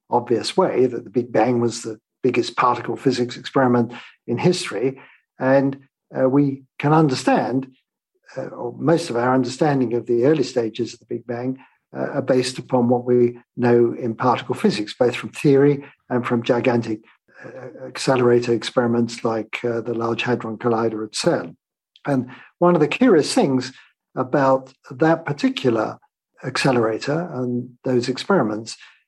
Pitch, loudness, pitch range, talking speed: 125 Hz, -20 LUFS, 120-135 Hz, 150 wpm